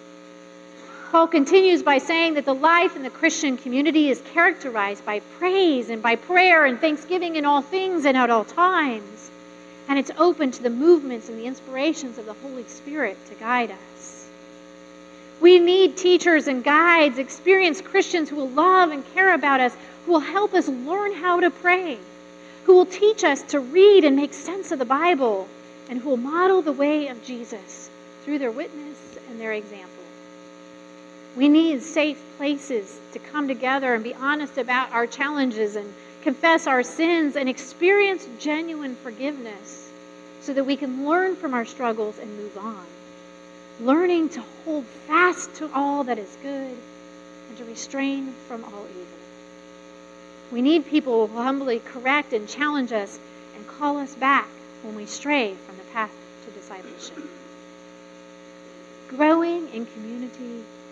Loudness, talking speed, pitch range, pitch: -21 LUFS, 160 wpm, 200-315 Hz, 270 Hz